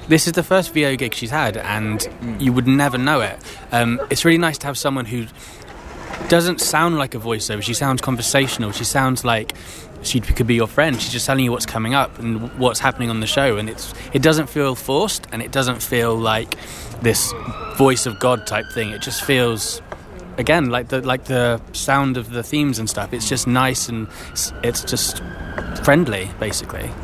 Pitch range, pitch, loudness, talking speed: 110-135 Hz, 125 Hz, -19 LUFS, 200 wpm